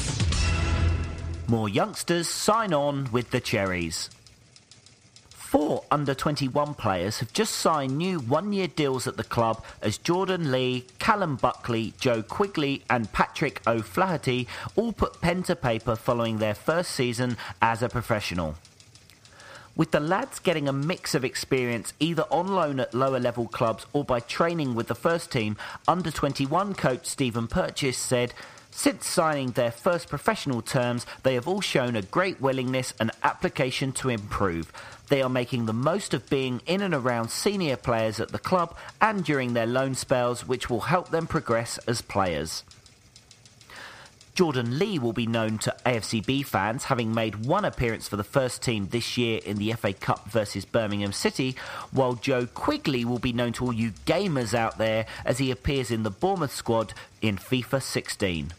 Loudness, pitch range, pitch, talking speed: -27 LUFS, 115-145 Hz, 125 Hz, 165 wpm